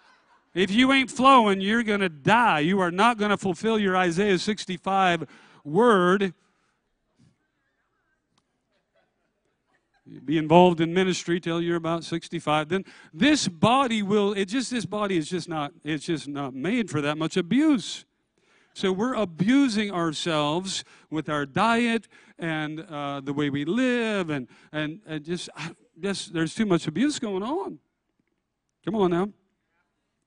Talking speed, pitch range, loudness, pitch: 145 wpm, 160-215 Hz, -24 LUFS, 185 Hz